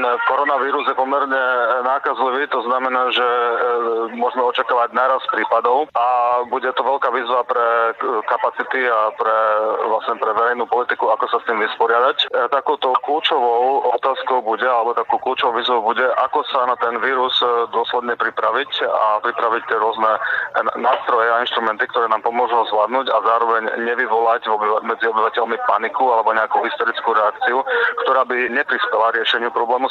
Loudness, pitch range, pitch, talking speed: -18 LUFS, 110-125 Hz, 115 Hz, 145 wpm